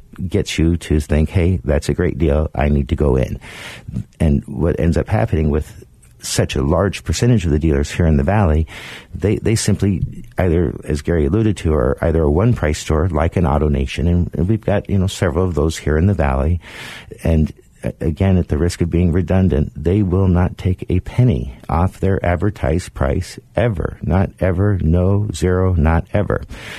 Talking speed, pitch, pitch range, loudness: 195 wpm, 85 Hz, 75-95 Hz, -17 LUFS